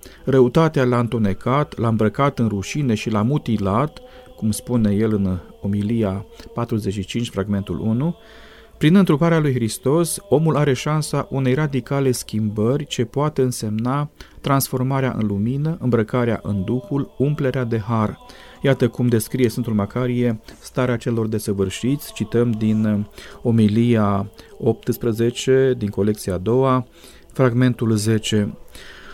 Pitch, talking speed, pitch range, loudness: 120 Hz, 120 wpm, 110-135 Hz, -20 LUFS